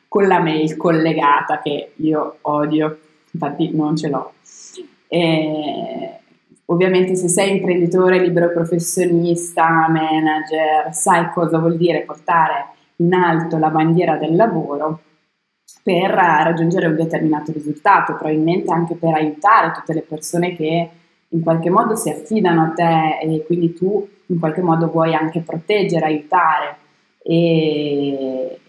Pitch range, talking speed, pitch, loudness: 155-175 Hz, 130 wpm, 165 Hz, -17 LUFS